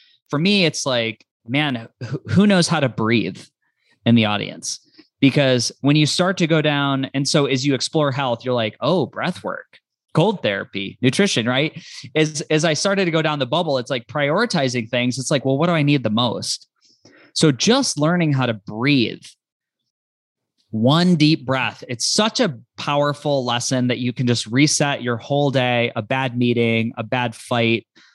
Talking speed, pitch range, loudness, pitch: 185 wpm, 120-155 Hz, -19 LUFS, 135 Hz